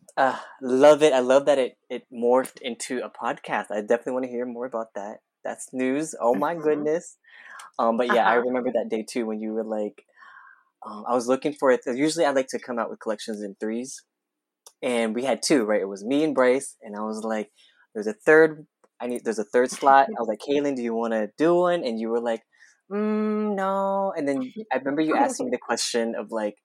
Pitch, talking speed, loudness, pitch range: 125 Hz, 230 wpm, -24 LUFS, 115-155 Hz